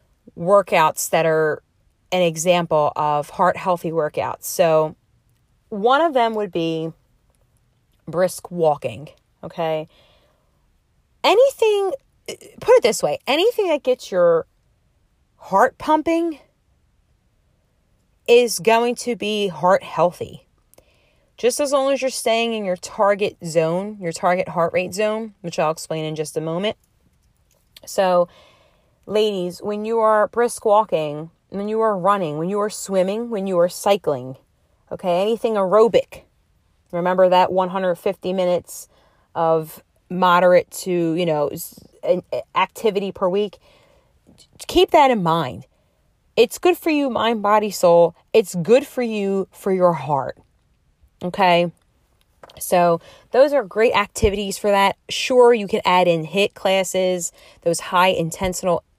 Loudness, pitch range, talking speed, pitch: -19 LUFS, 170-225 Hz, 130 wpm, 190 Hz